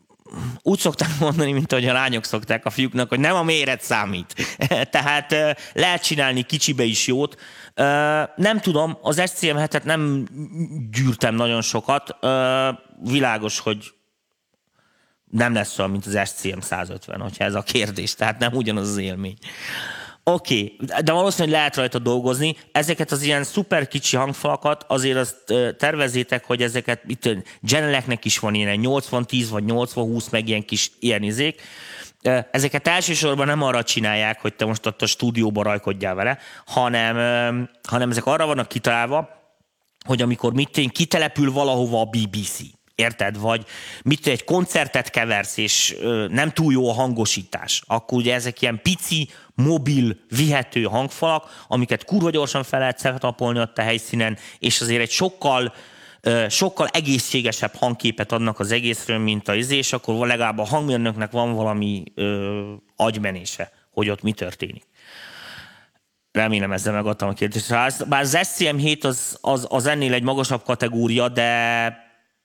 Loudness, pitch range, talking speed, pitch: -21 LUFS, 110-145 Hz, 145 wpm, 125 Hz